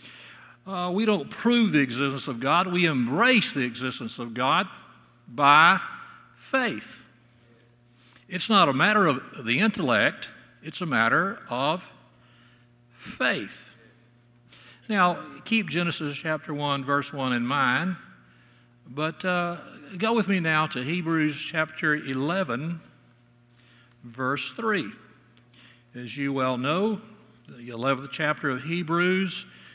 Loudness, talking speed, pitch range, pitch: -25 LUFS, 115 wpm, 120-175 Hz, 140 Hz